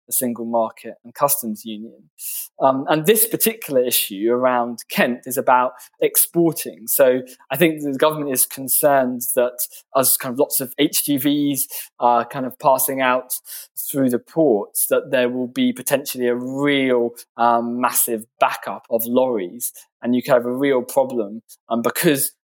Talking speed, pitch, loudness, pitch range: 160 wpm, 125 Hz, -19 LUFS, 120-145 Hz